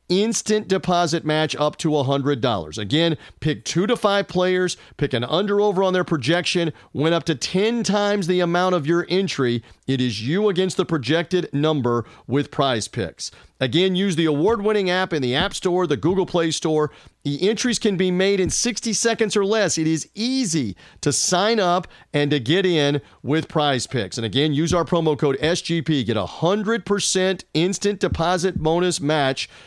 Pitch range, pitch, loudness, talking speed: 145-190 Hz, 170 Hz, -21 LUFS, 180 wpm